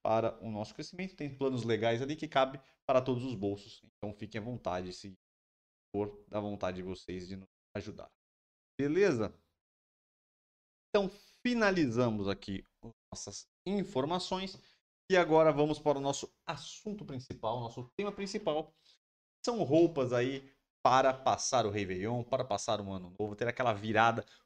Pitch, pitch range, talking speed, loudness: 120 Hz, 100-155 Hz, 145 wpm, -33 LUFS